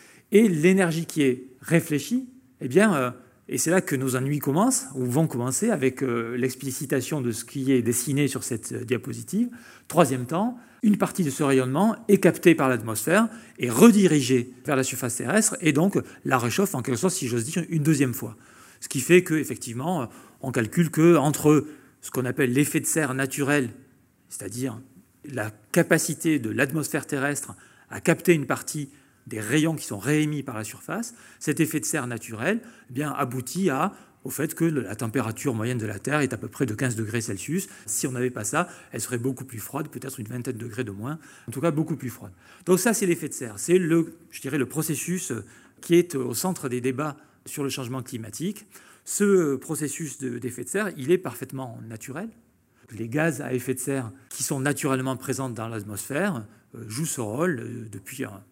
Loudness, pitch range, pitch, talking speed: -25 LUFS, 125-165 Hz, 135 Hz, 195 wpm